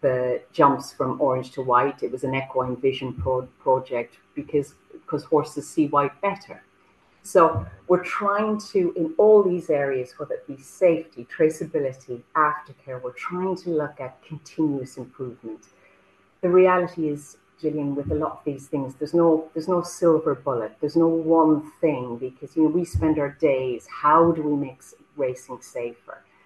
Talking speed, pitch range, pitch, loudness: 165 wpm, 130-165 Hz, 150 Hz, -23 LUFS